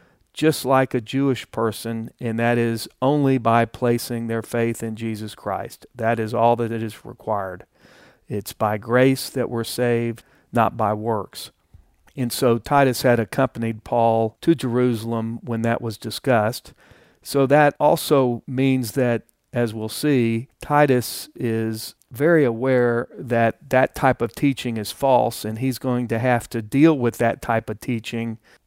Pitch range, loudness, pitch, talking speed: 115-130 Hz, -21 LUFS, 120 Hz, 155 wpm